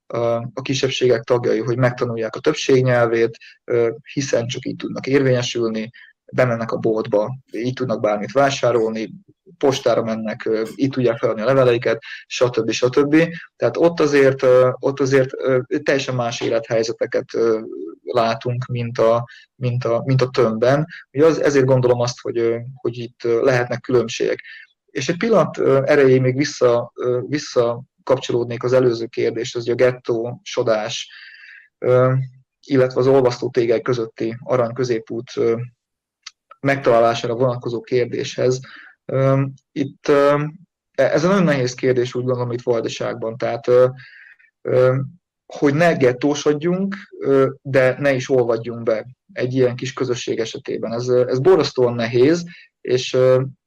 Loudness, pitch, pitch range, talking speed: -19 LUFS, 125 Hz, 120-135 Hz, 120 wpm